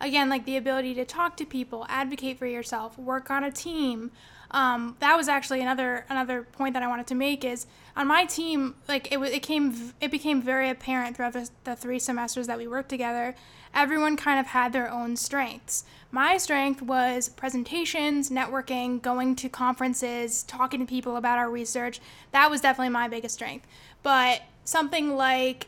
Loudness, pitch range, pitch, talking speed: -27 LUFS, 245-275 Hz, 260 Hz, 185 wpm